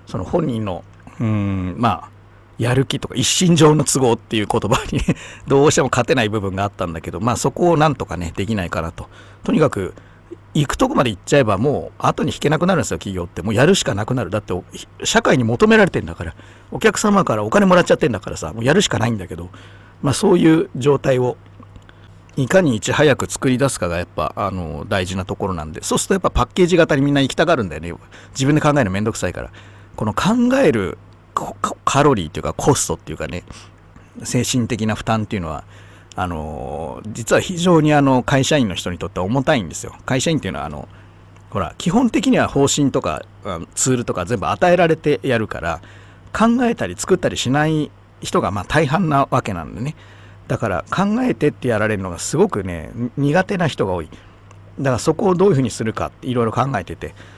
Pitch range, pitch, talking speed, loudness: 95-145 Hz, 110 Hz, 420 characters per minute, -18 LUFS